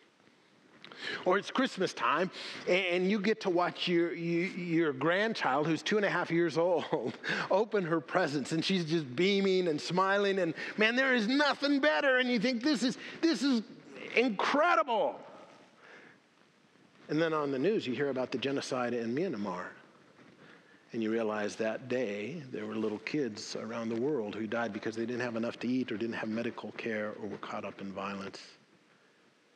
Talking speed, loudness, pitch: 175 wpm, -31 LUFS, 165 Hz